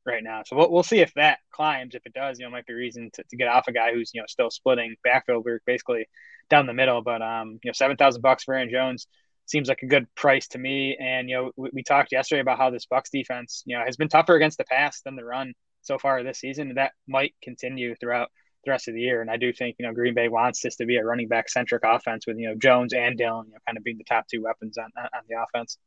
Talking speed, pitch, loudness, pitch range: 280 wpm, 125 Hz, -24 LUFS, 120-135 Hz